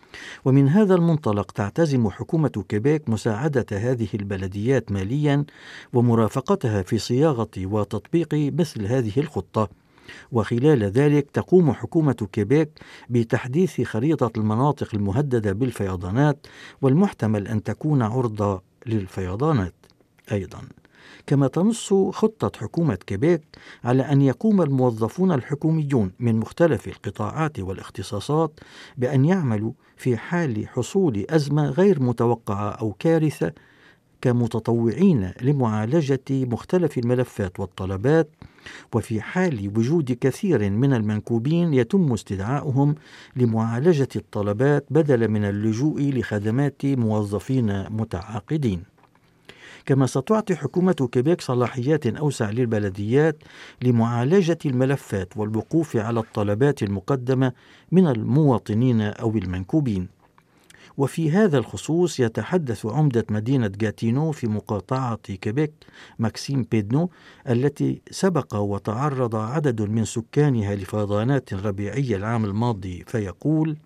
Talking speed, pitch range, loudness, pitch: 95 wpm, 110-145 Hz, -23 LUFS, 125 Hz